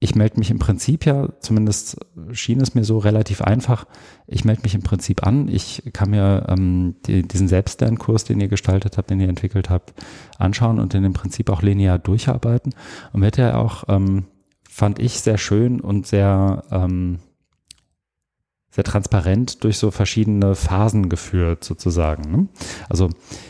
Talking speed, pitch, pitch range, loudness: 165 wpm, 100 Hz, 95-115 Hz, -19 LUFS